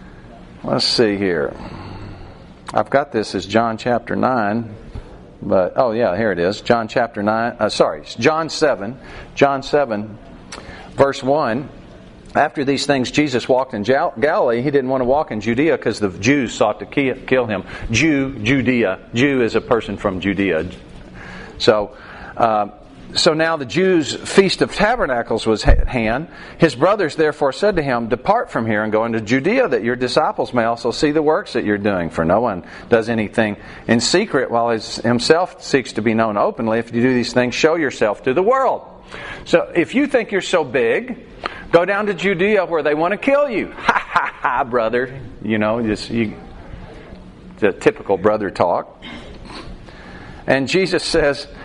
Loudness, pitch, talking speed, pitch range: -18 LUFS, 120 Hz, 175 wpm, 110-150 Hz